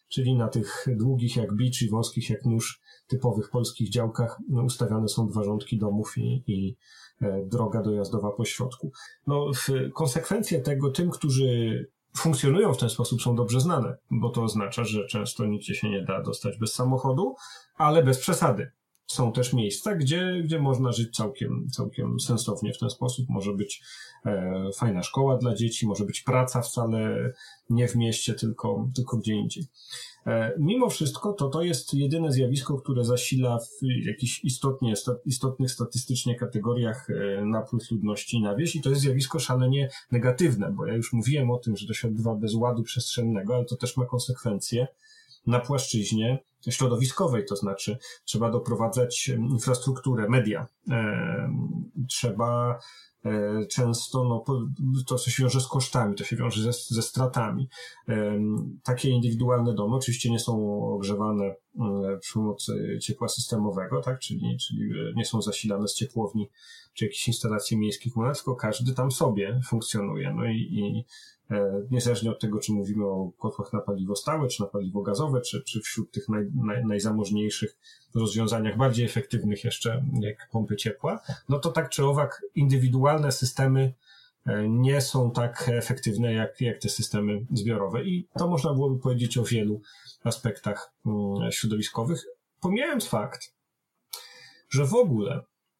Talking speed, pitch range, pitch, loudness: 155 wpm, 110-130 Hz, 120 Hz, -27 LUFS